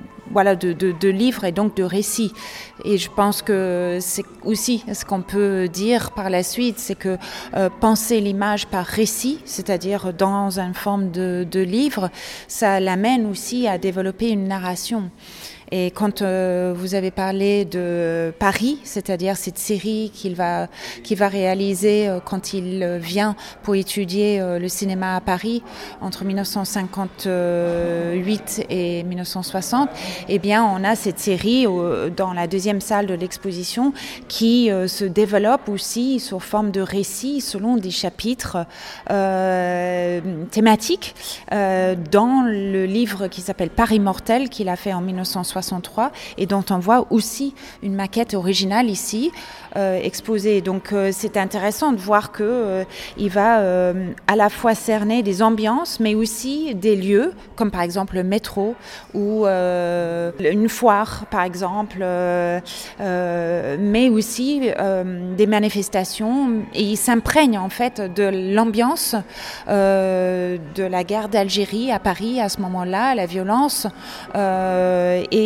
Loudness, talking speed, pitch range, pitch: -20 LUFS, 145 wpm, 185-220 Hz, 200 Hz